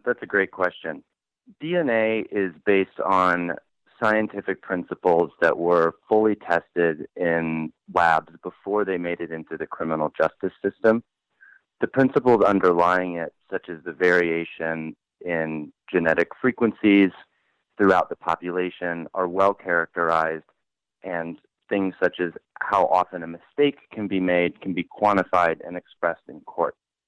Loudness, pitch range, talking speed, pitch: -23 LUFS, 85-100 Hz, 135 wpm, 90 Hz